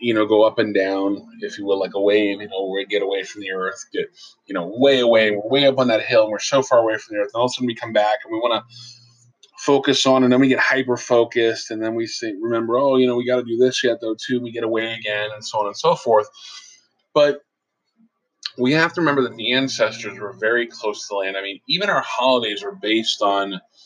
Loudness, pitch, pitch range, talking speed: -19 LUFS, 120 Hz, 105-135 Hz, 270 wpm